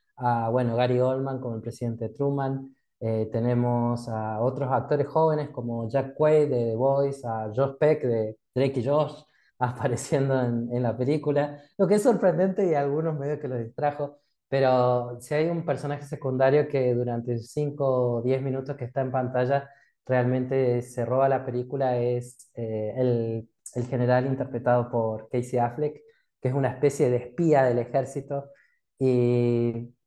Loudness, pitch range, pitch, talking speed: -26 LUFS, 120-145 Hz, 130 Hz, 160 wpm